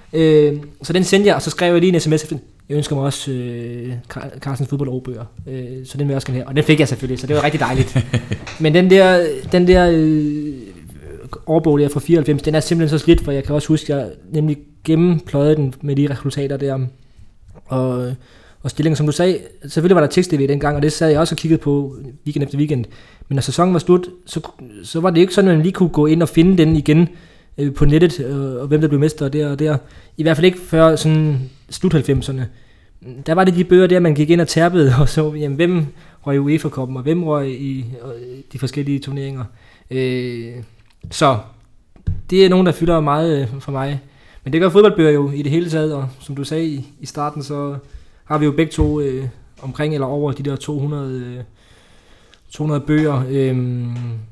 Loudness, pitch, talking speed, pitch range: -16 LUFS, 145 Hz, 215 wpm, 130-160 Hz